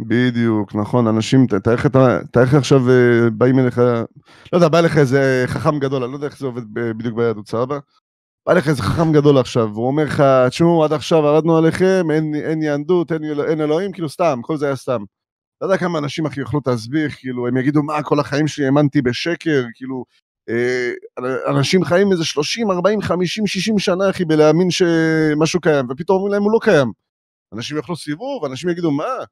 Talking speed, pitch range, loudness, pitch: 185 wpm, 125-165 Hz, -17 LUFS, 145 Hz